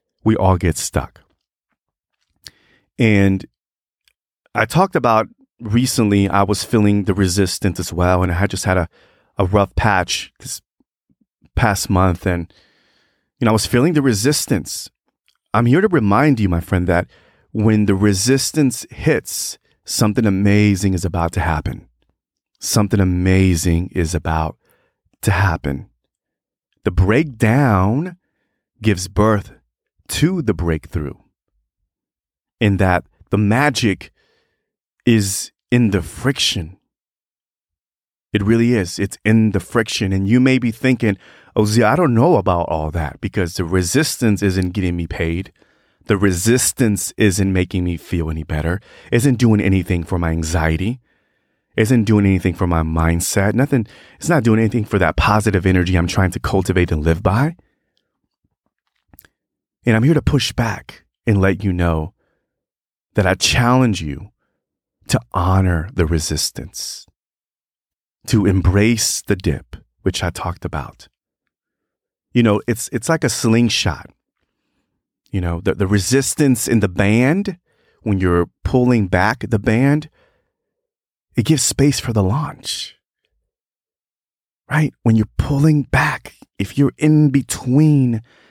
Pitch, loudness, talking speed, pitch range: 100 Hz, -17 LUFS, 135 wpm, 90-120 Hz